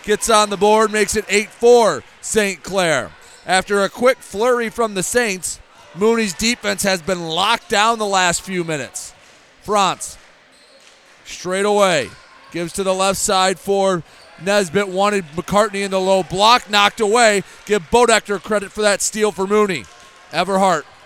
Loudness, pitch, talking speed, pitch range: -17 LUFS, 200 Hz, 150 wpm, 185-215 Hz